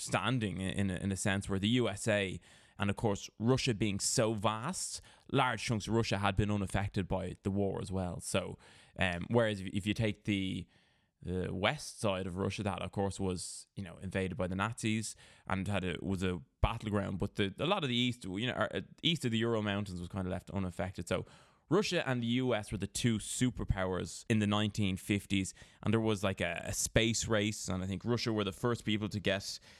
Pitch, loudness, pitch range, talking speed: 100 Hz, -34 LUFS, 95-110 Hz, 210 wpm